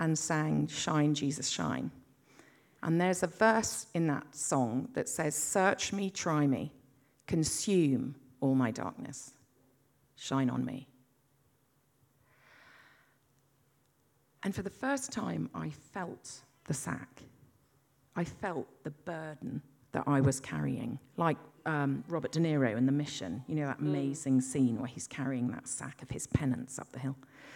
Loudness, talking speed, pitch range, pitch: -33 LUFS, 145 wpm, 130-155 Hz, 140 Hz